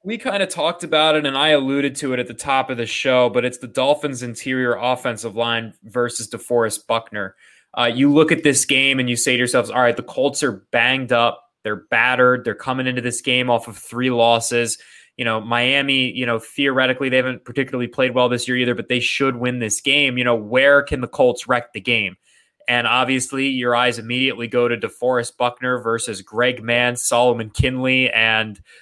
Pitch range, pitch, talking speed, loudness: 120-130 Hz, 125 Hz, 210 wpm, -18 LUFS